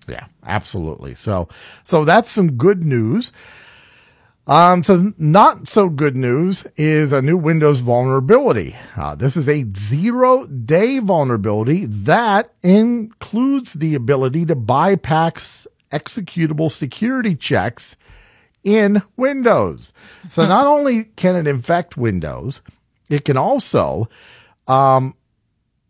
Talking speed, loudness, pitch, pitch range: 110 wpm, -16 LUFS, 160 Hz, 130-205 Hz